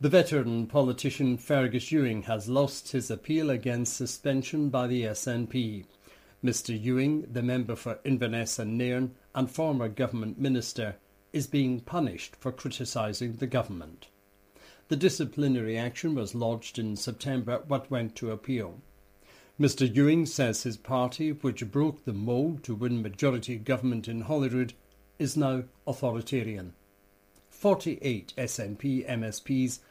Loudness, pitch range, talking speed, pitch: -30 LUFS, 115-135 Hz, 130 wpm, 125 Hz